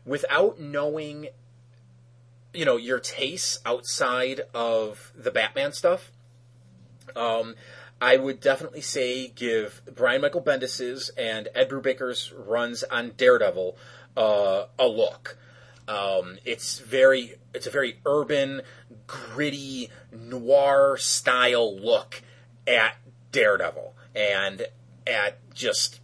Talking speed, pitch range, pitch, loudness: 105 wpm, 120-135 Hz, 125 Hz, -25 LUFS